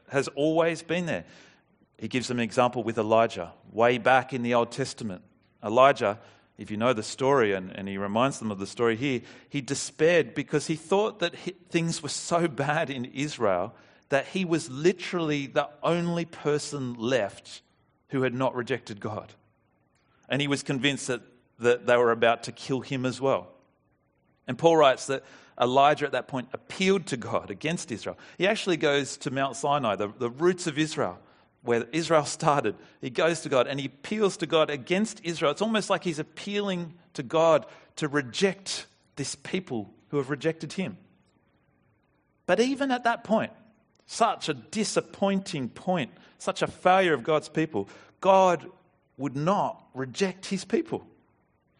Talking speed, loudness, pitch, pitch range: 170 wpm, -27 LUFS, 145 Hz, 125-175 Hz